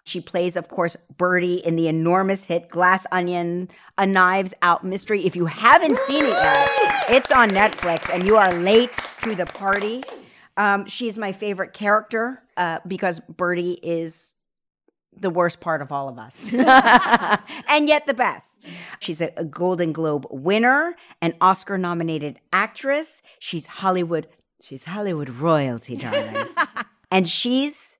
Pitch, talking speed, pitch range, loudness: 185 Hz, 145 wpm, 170-230 Hz, -20 LUFS